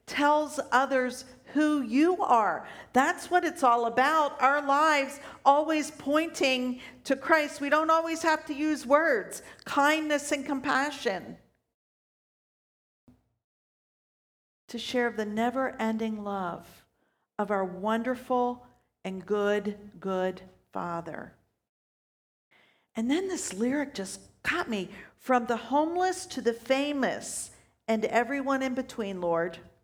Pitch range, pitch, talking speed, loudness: 225-295 Hz, 260 Hz, 115 wpm, -28 LUFS